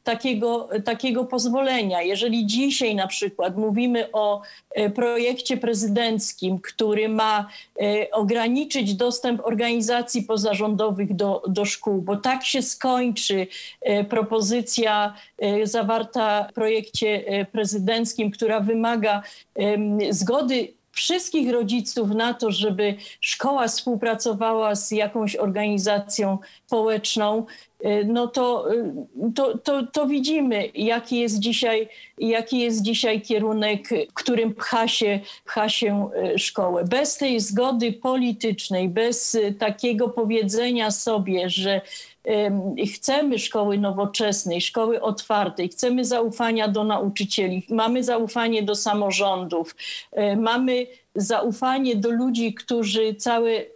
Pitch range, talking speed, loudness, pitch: 210-240 Hz, 105 wpm, -23 LUFS, 225 Hz